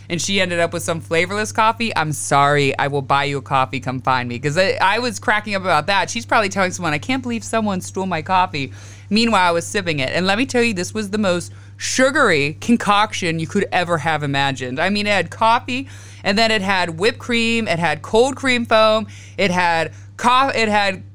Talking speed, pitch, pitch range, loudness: 225 wpm, 180 Hz, 140-220 Hz, -18 LUFS